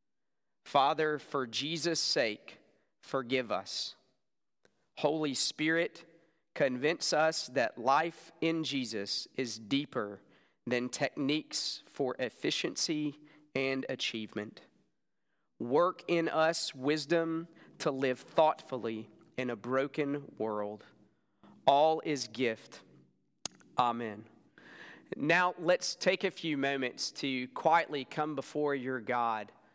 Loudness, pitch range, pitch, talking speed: -33 LUFS, 125-160 Hz, 145 Hz, 100 wpm